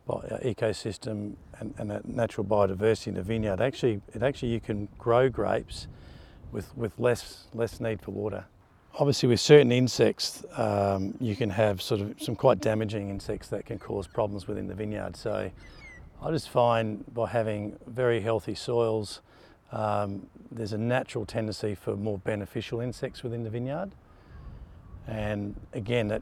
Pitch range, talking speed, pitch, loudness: 105-120 Hz, 155 wpm, 110 Hz, -29 LUFS